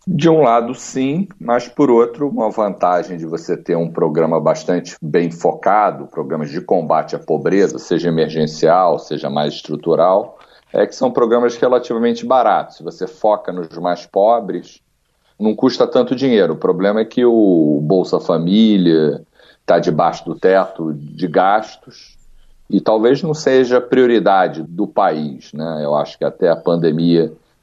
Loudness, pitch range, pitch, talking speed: -16 LUFS, 80-120 Hz, 105 Hz, 150 wpm